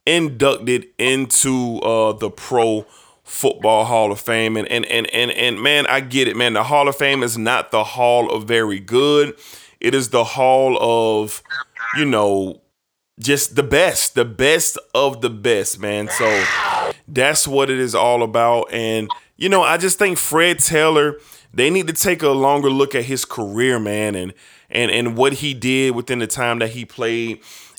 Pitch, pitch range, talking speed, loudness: 125 Hz, 115-140 Hz, 180 wpm, -17 LUFS